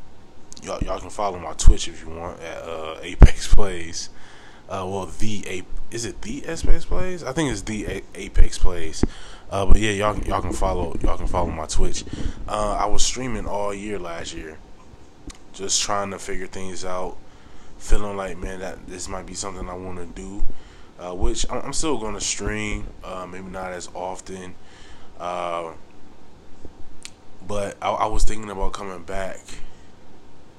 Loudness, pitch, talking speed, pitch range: -26 LUFS, 95 Hz, 170 wpm, 90-105 Hz